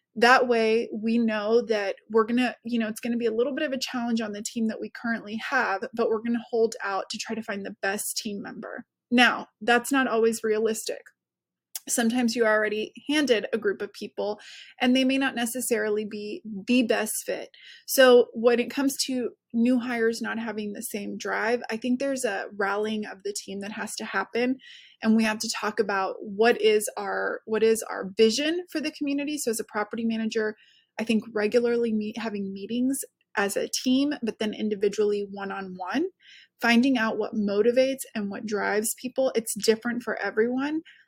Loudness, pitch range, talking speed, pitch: -26 LUFS, 215-250 Hz, 195 wpm, 230 Hz